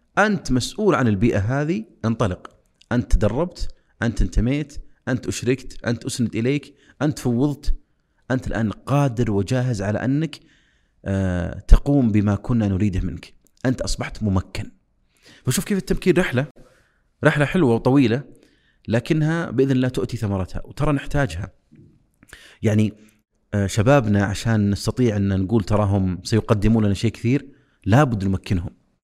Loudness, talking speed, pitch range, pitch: -21 LUFS, 120 wpm, 100-140 Hz, 120 Hz